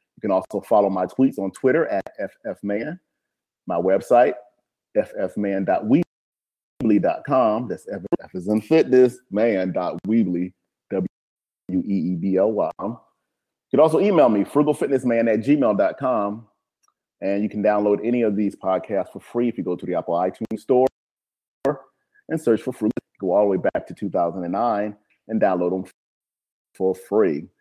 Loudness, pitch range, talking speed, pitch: -22 LUFS, 95-120 Hz, 135 wpm, 105 Hz